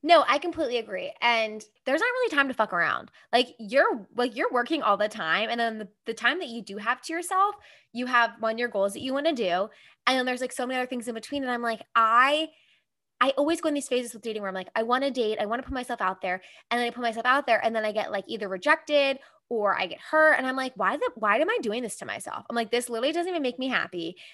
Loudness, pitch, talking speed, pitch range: -26 LUFS, 245 Hz, 285 wpm, 225-285 Hz